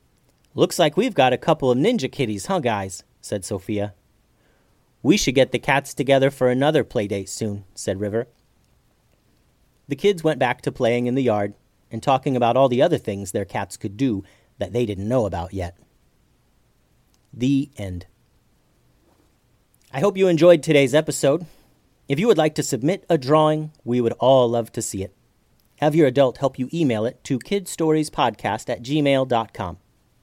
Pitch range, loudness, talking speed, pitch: 105-145 Hz, -21 LUFS, 170 wpm, 125 Hz